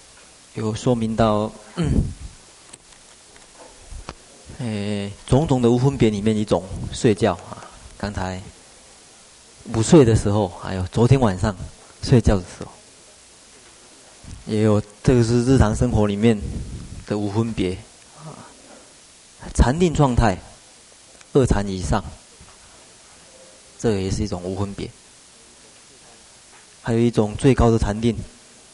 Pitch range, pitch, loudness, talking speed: 100-115 Hz, 110 Hz, -20 LUFS, 160 characters per minute